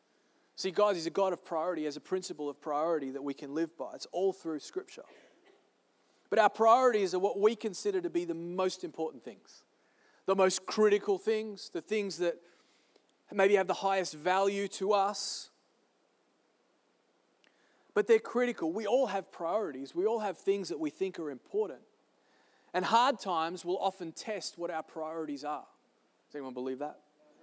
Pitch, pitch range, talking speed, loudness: 190 Hz, 160-220 Hz, 170 wpm, -32 LUFS